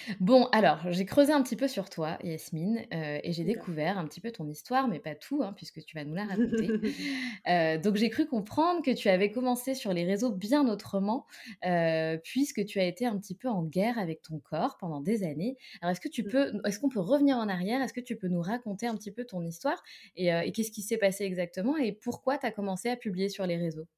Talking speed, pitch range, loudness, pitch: 250 wpm, 175-245 Hz, -30 LUFS, 205 Hz